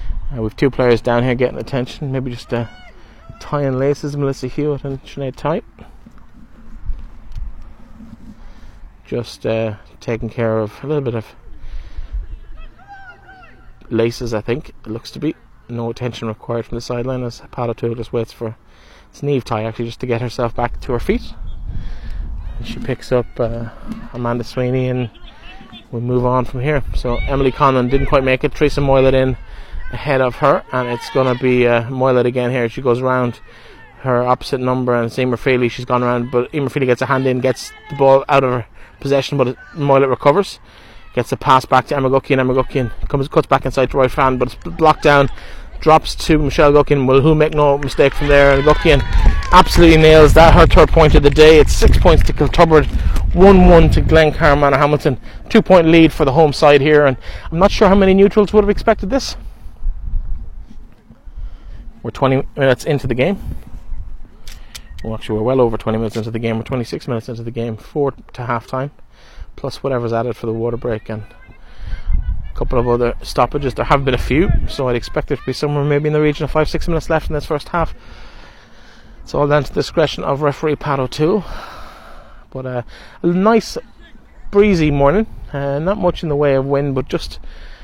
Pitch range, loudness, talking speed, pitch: 115-145 Hz, -15 LUFS, 190 wpm, 130 Hz